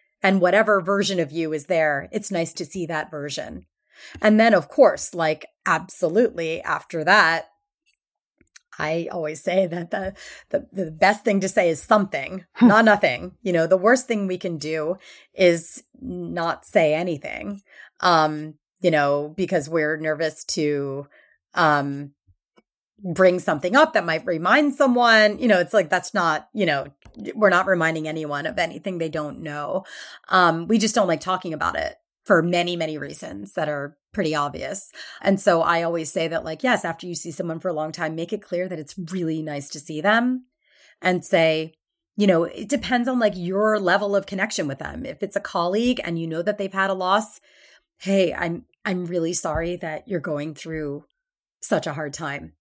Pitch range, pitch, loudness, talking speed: 160-205 Hz, 175 Hz, -22 LUFS, 185 wpm